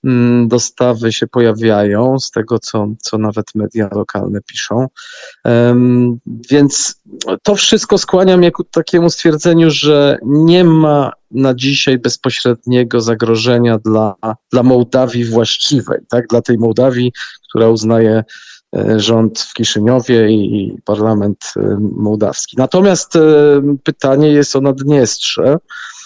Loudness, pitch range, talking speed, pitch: -12 LUFS, 115-140 Hz, 110 wpm, 120 Hz